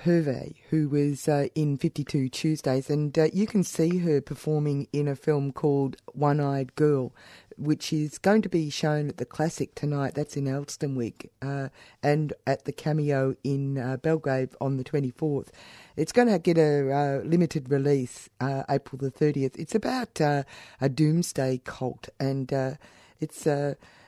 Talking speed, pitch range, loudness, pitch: 165 wpm, 135-155 Hz, -27 LUFS, 145 Hz